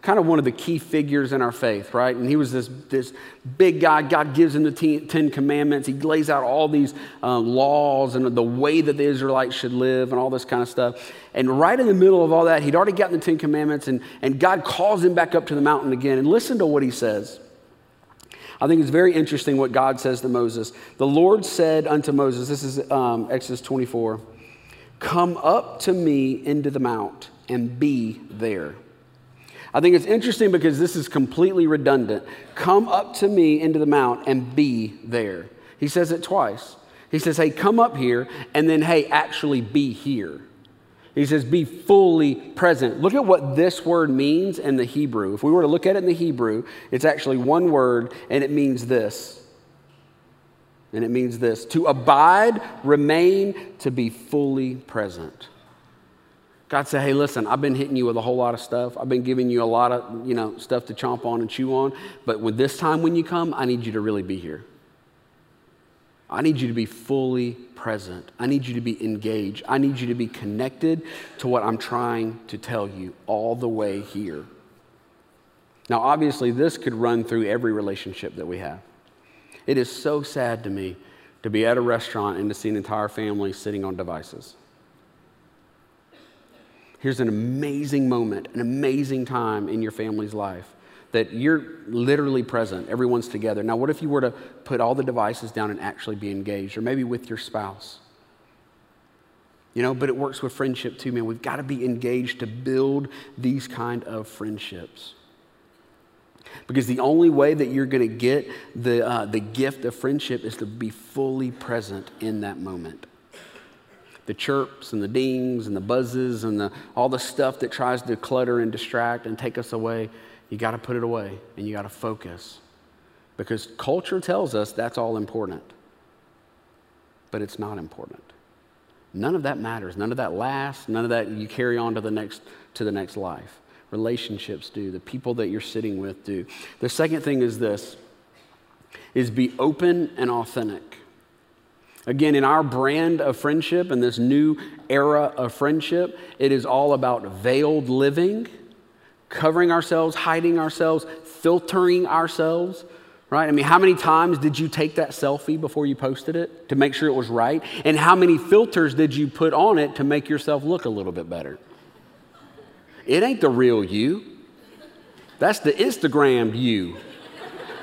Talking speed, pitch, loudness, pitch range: 190 wpm, 130 Hz, -22 LUFS, 115-150 Hz